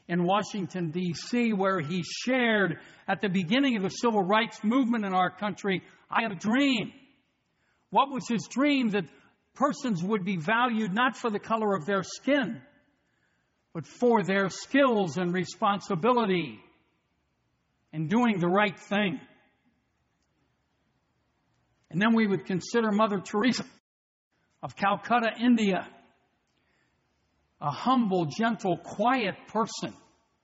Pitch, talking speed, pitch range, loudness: 205 Hz, 125 wpm, 185-235 Hz, -27 LUFS